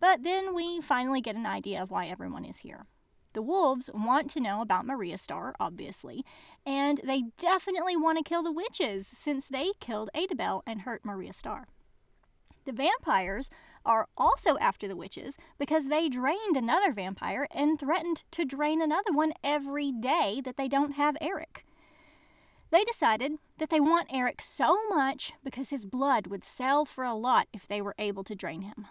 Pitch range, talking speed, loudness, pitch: 250-320 Hz, 175 wpm, -30 LUFS, 280 Hz